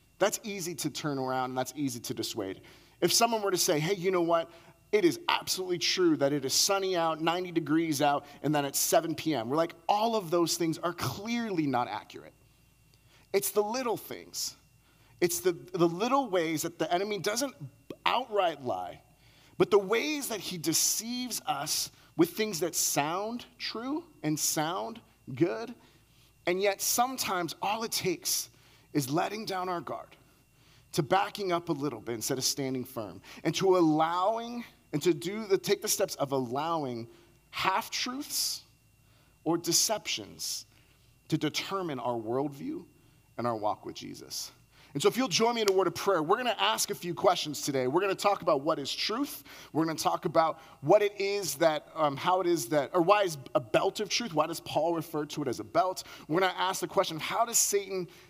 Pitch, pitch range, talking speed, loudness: 170 Hz, 145-195 Hz, 195 wpm, -30 LUFS